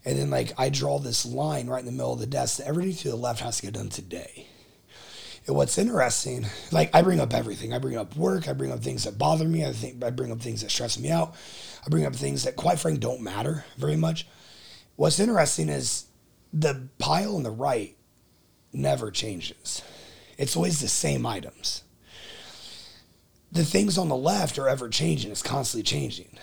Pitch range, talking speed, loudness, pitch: 115-160 Hz, 205 wpm, -26 LUFS, 130 Hz